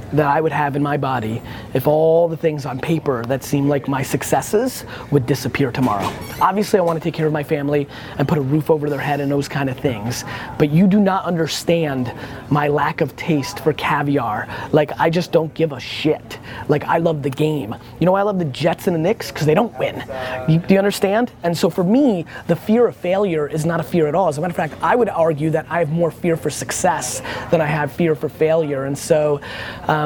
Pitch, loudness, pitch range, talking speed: 150 Hz, -19 LUFS, 140-165 Hz, 245 wpm